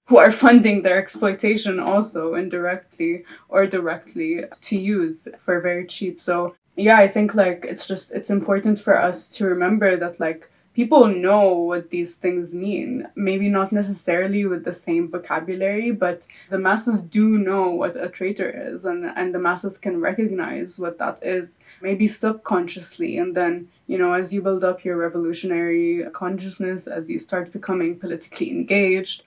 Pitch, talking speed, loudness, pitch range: 185 Hz, 160 wpm, -21 LUFS, 175-205 Hz